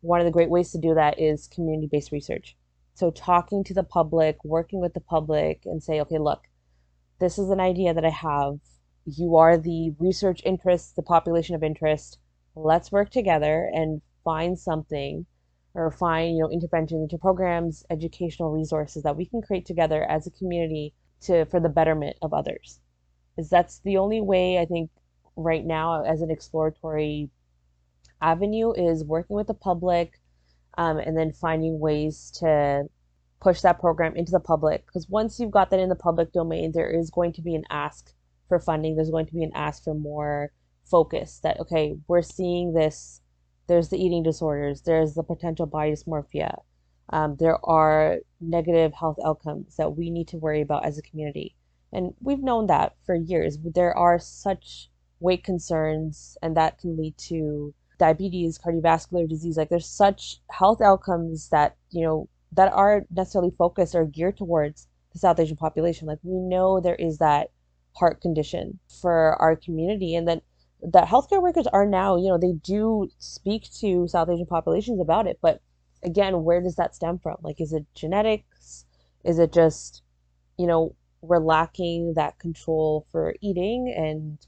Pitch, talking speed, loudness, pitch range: 165 Hz, 175 wpm, -24 LUFS, 150-175 Hz